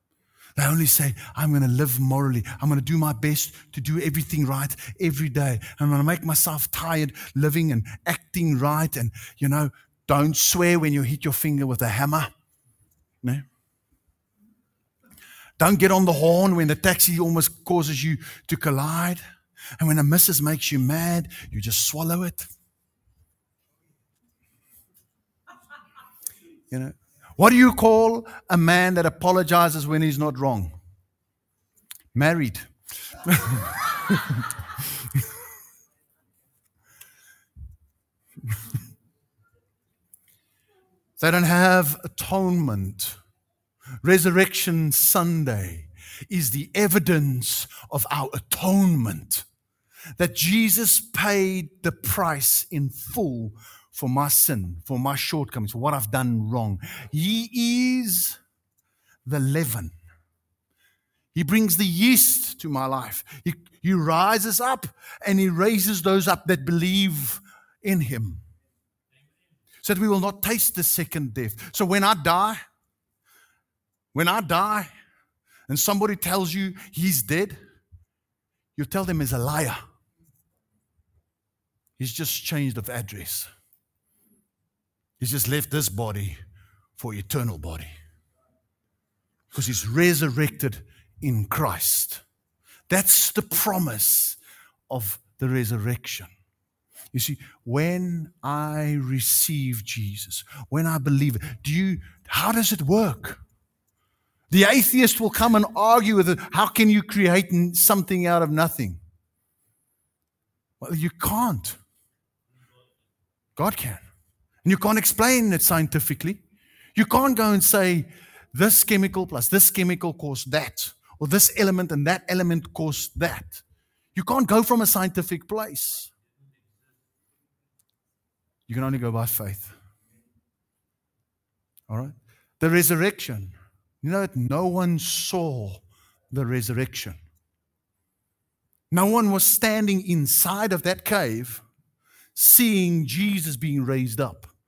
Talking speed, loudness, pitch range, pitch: 120 wpm, -21 LUFS, 110-175 Hz, 145 Hz